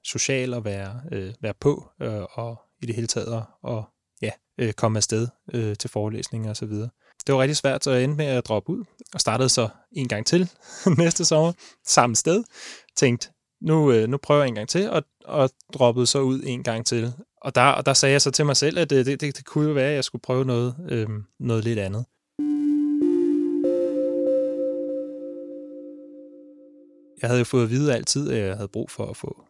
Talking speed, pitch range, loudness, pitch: 205 wpm, 115-175 Hz, -23 LUFS, 135 Hz